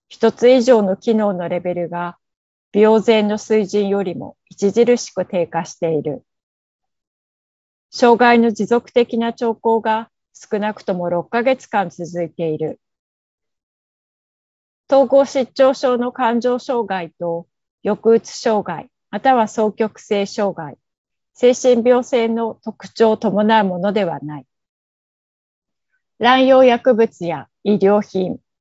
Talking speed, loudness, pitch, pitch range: 210 characters per minute, -17 LUFS, 215 Hz, 185-240 Hz